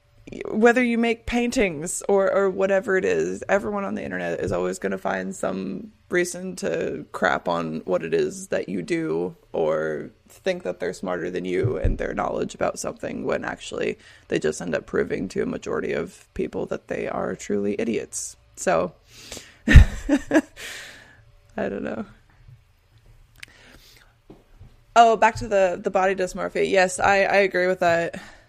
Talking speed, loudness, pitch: 160 wpm, -23 LUFS, 185 Hz